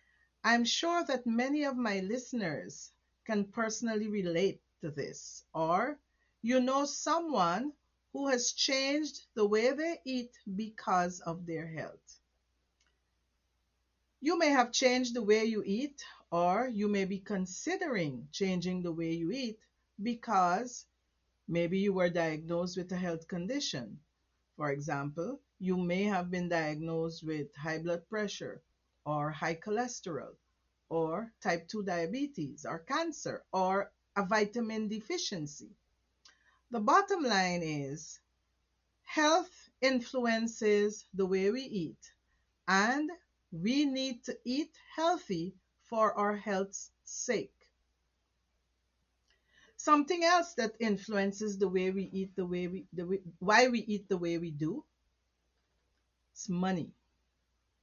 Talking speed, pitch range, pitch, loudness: 125 wpm, 165-245 Hz, 195 Hz, -33 LUFS